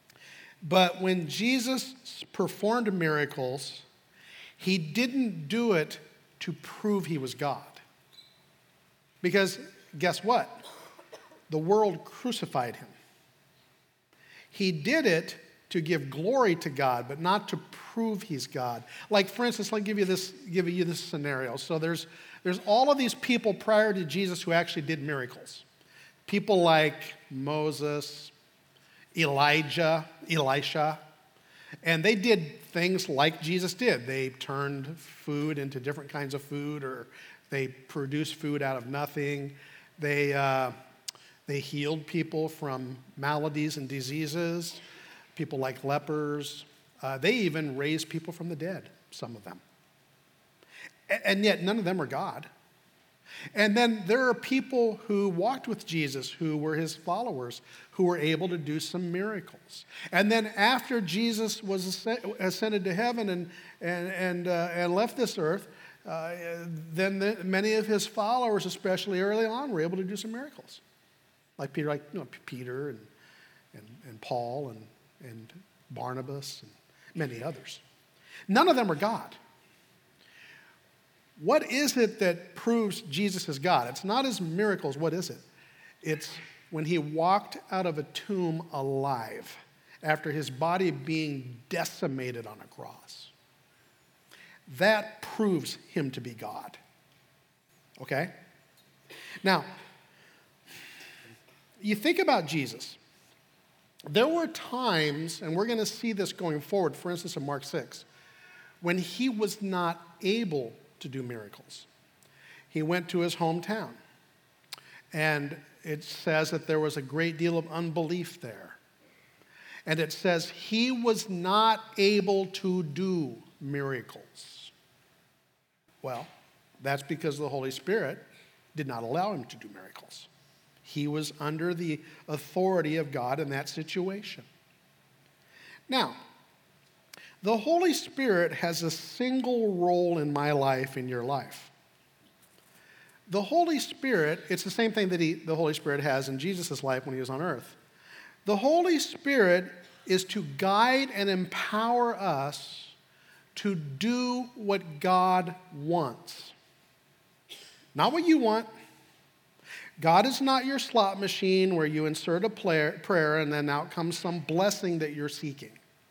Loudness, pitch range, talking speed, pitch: -29 LUFS, 150-200 Hz, 140 wpm, 170 Hz